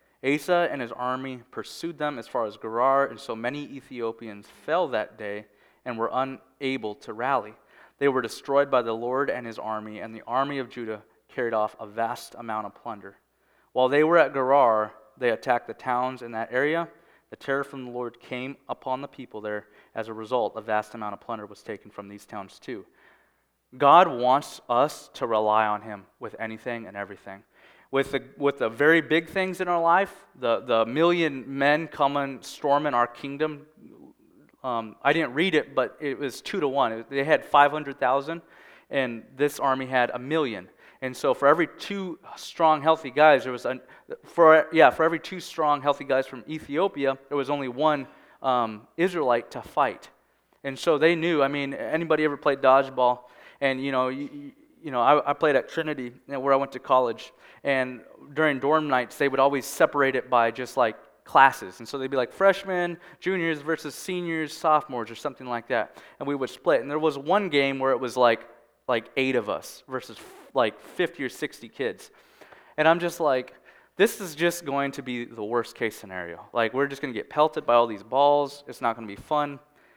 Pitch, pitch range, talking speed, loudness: 135 Hz, 120-150 Hz, 205 wpm, -25 LUFS